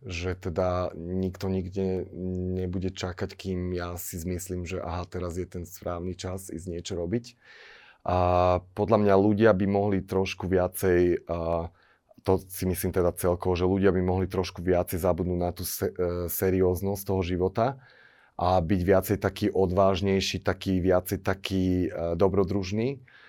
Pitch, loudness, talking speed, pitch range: 95 Hz, -27 LUFS, 140 wpm, 90-95 Hz